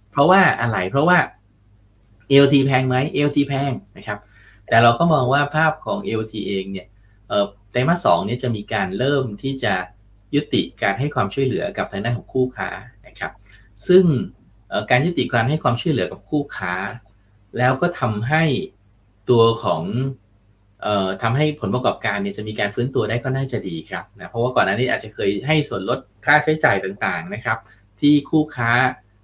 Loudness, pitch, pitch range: -20 LUFS, 120 Hz, 105-140 Hz